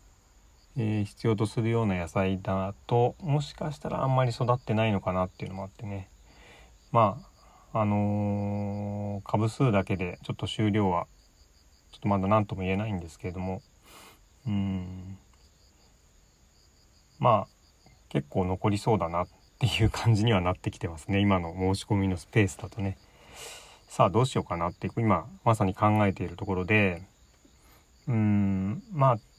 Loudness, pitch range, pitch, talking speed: -28 LUFS, 90-110 Hz, 100 Hz, 310 characters per minute